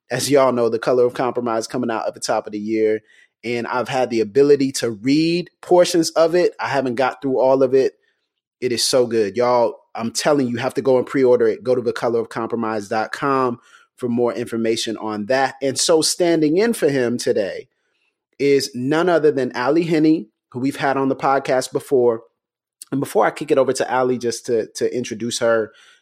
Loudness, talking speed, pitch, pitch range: -19 LUFS, 205 wpm, 130 Hz, 115-155 Hz